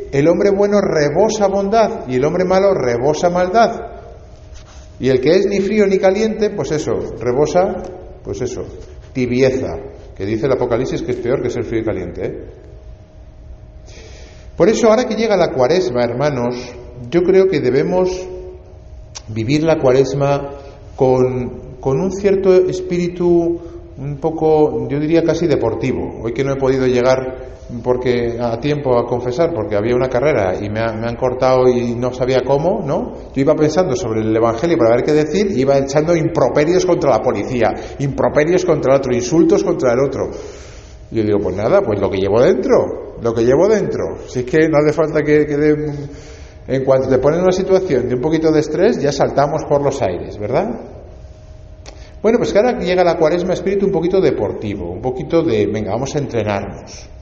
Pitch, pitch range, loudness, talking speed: 140 Hz, 120-175 Hz, -16 LUFS, 185 wpm